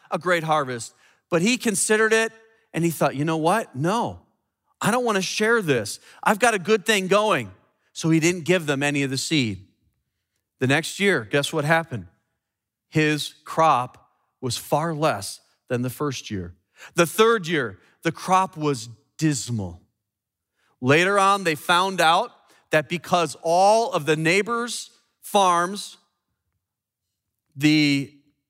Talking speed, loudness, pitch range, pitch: 145 wpm, -22 LUFS, 130-190 Hz, 160 Hz